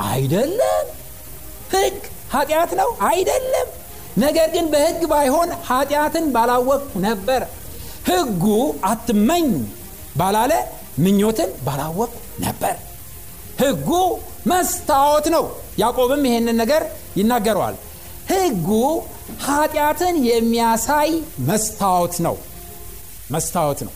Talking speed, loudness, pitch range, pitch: 80 wpm, -19 LUFS, 190-305 Hz, 240 Hz